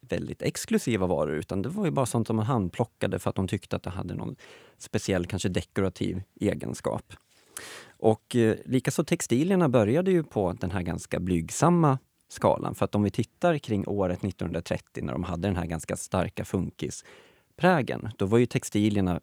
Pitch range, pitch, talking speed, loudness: 95-130 Hz, 105 Hz, 175 wpm, -28 LUFS